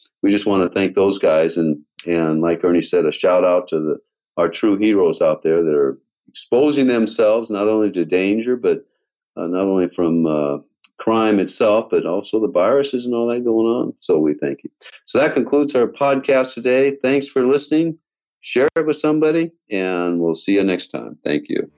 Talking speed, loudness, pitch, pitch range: 200 wpm, -18 LUFS, 115 Hz, 90-150 Hz